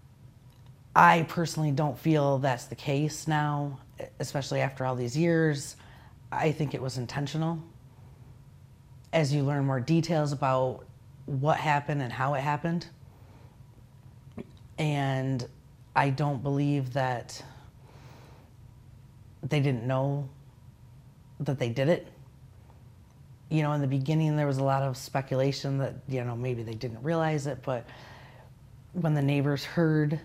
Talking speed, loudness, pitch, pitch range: 130 wpm, -29 LUFS, 135 Hz, 125-145 Hz